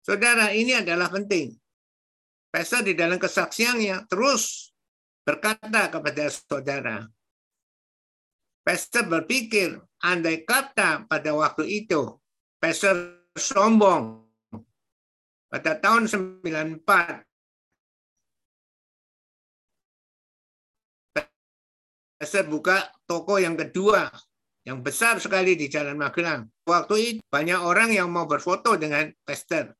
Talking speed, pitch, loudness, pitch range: 90 wpm, 175 Hz, -23 LUFS, 150-205 Hz